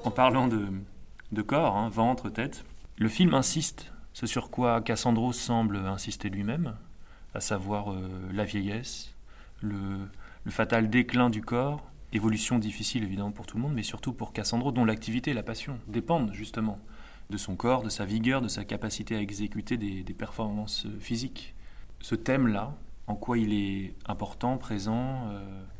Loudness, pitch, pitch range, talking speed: -30 LUFS, 110 Hz, 100-120 Hz, 165 wpm